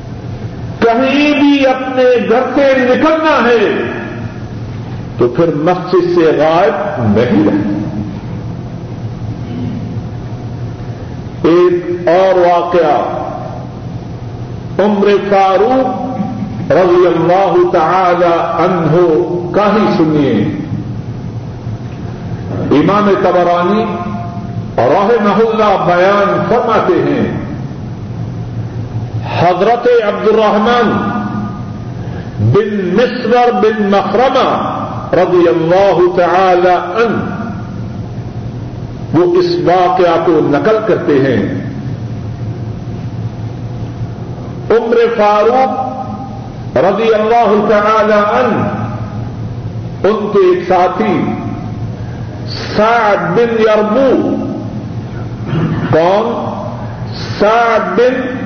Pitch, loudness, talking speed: 175 Hz, -12 LUFS, 65 wpm